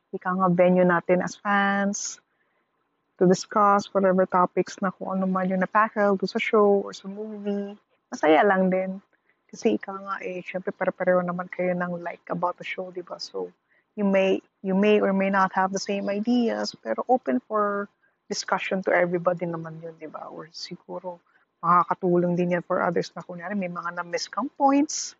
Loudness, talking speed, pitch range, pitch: -24 LUFS, 180 wpm, 180-200 Hz, 190 Hz